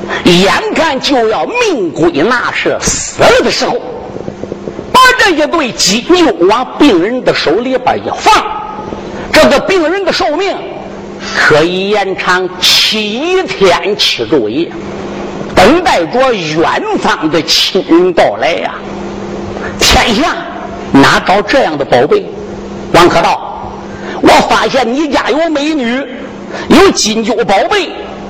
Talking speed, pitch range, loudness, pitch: 170 characters per minute, 225-365 Hz, -9 LUFS, 300 Hz